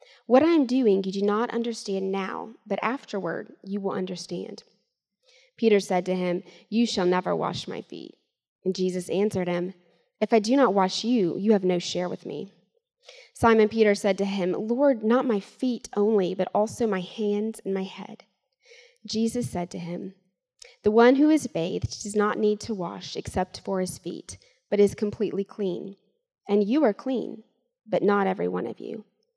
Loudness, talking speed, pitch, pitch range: -25 LUFS, 180 wpm, 205 Hz, 185-235 Hz